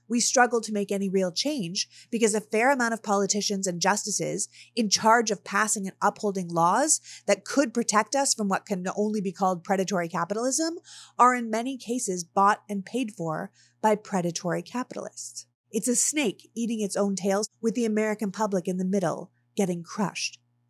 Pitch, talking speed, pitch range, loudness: 205 Hz, 175 wpm, 185-230 Hz, -26 LUFS